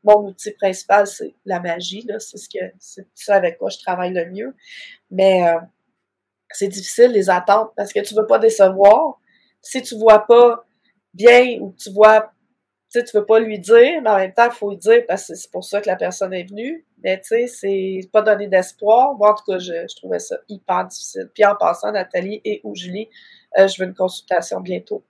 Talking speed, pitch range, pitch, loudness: 215 wpm, 190-235 Hz, 210 Hz, -16 LUFS